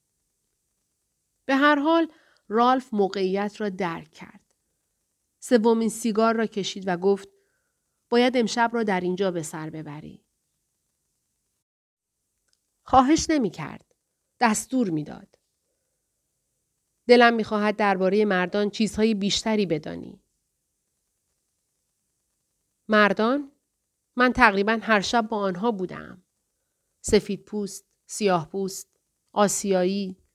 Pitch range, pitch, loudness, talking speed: 195-240 Hz, 210 Hz, -23 LUFS, 95 wpm